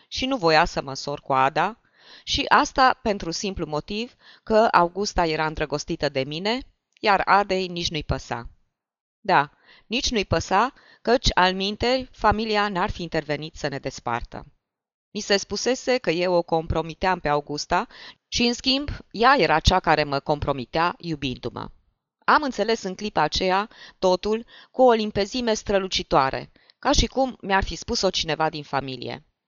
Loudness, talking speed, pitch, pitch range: -23 LUFS, 155 wpm, 180 Hz, 150-215 Hz